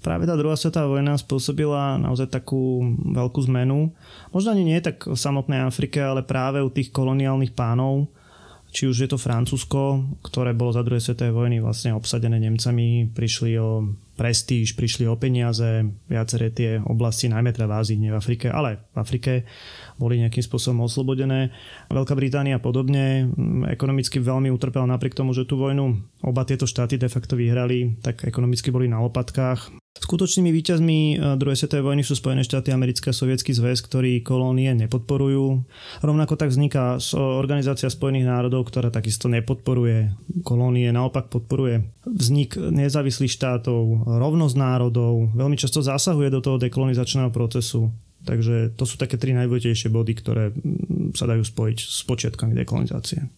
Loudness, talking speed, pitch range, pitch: -22 LUFS, 150 wpm, 120-135 Hz, 130 Hz